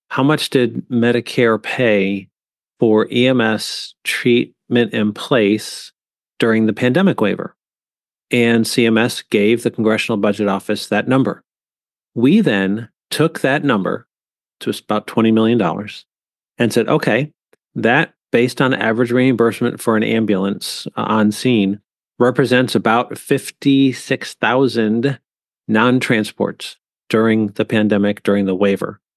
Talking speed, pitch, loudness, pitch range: 115 wpm, 115 Hz, -16 LUFS, 105-125 Hz